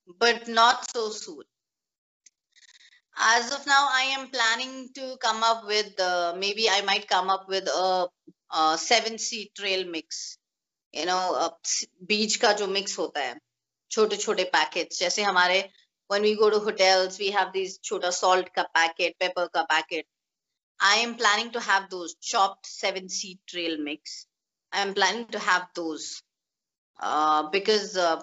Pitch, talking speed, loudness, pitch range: 195 Hz, 160 wpm, -25 LUFS, 180-220 Hz